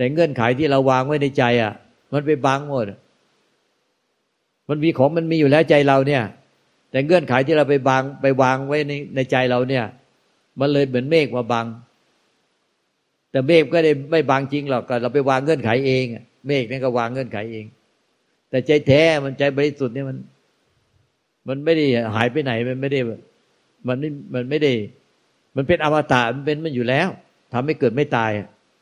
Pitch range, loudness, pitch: 125-150 Hz, -19 LUFS, 135 Hz